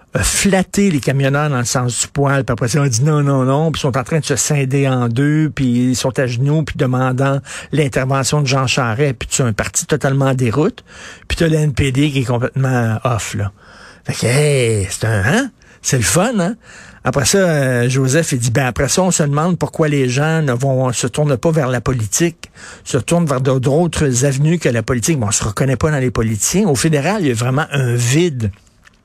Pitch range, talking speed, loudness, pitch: 125-150 Hz, 225 wpm, -15 LUFS, 135 Hz